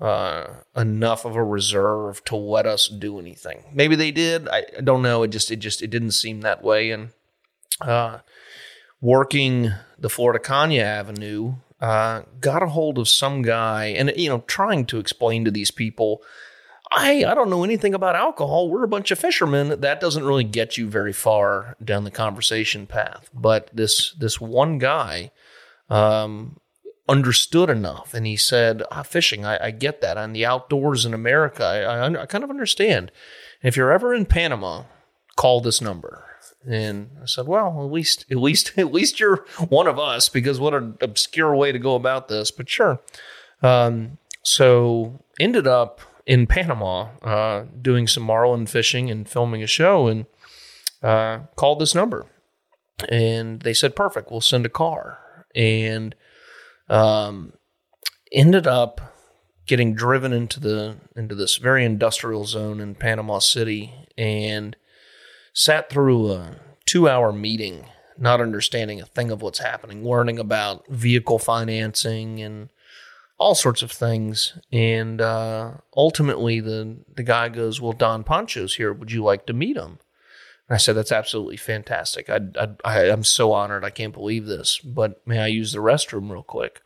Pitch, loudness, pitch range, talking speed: 115 Hz, -20 LUFS, 110-135 Hz, 165 wpm